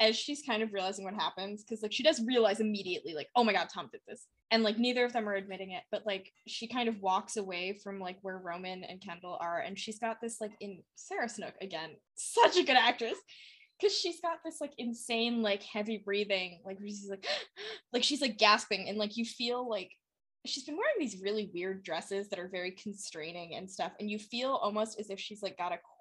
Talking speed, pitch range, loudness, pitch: 230 wpm, 190-235 Hz, -34 LUFS, 210 Hz